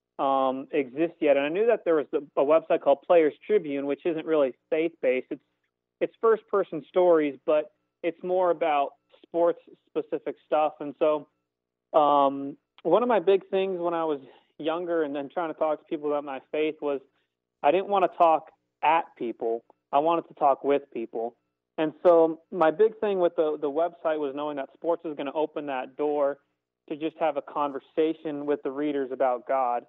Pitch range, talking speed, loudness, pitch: 140-170 Hz, 195 wpm, -26 LUFS, 155 Hz